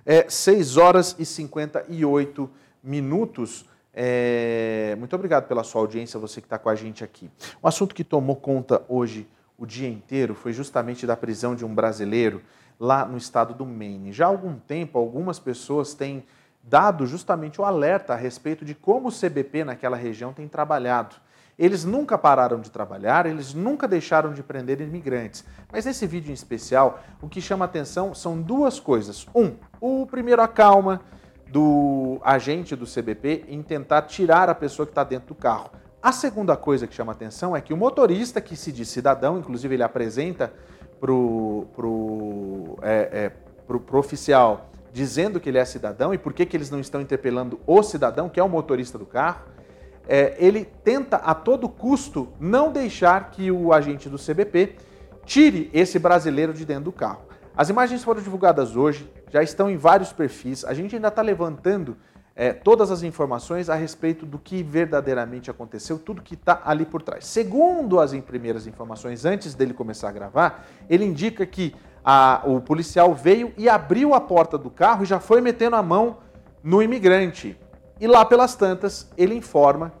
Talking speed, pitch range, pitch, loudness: 180 wpm, 125-185 Hz, 150 Hz, -21 LUFS